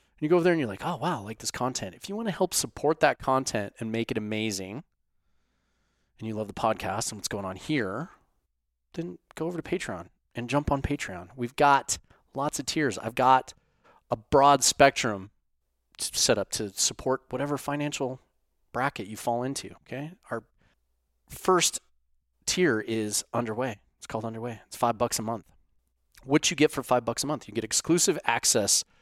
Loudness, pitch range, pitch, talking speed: -27 LUFS, 95-145 Hz, 120 Hz, 190 wpm